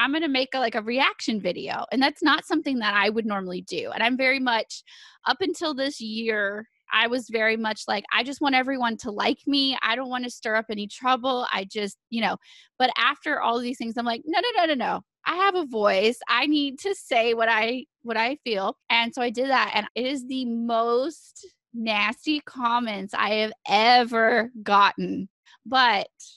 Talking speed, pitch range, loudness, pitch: 210 wpm, 220-270 Hz, -24 LUFS, 240 Hz